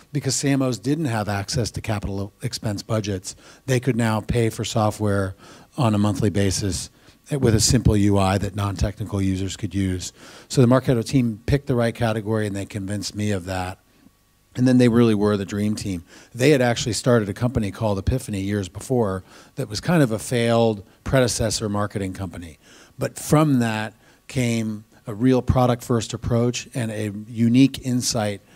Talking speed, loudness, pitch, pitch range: 175 wpm, -22 LUFS, 110 Hz, 100-125 Hz